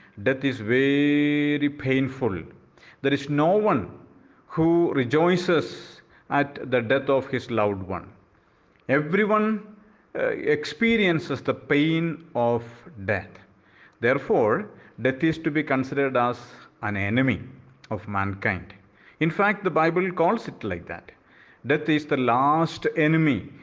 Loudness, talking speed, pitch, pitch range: -24 LUFS, 120 wpm, 140 Hz, 115-160 Hz